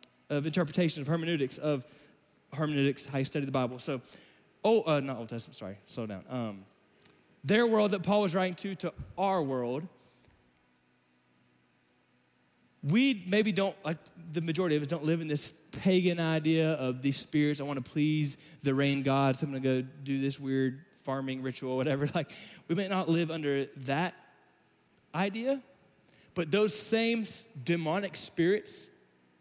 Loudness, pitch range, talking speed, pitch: -31 LUFS, 130-180 Hz, 160 wpm, 150 Hz